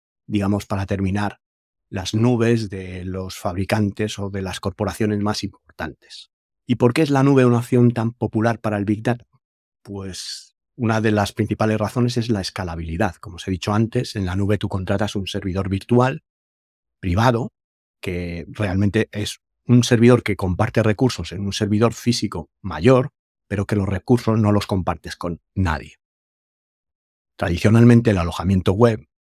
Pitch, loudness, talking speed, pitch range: 105 Hz, -20 LUFS, 160 wpm, 95-115 Hz